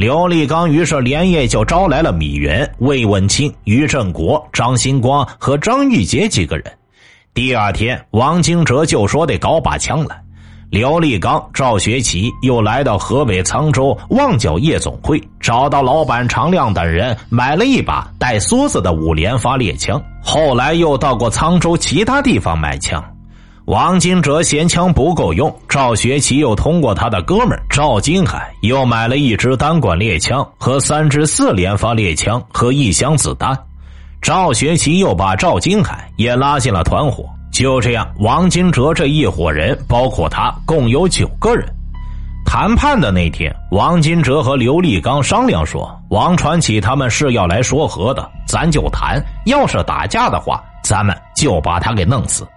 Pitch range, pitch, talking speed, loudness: 105-150 Hz, 125 Hz, 240 characters per minute, -14 LUFS